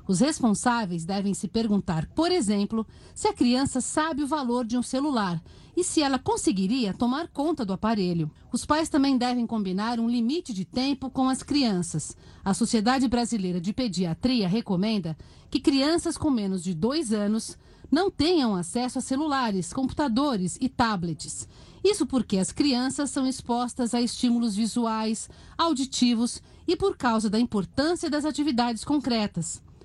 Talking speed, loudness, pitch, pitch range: 150 wpm, -26 LUFS, 245 Hz, 210-280 Hz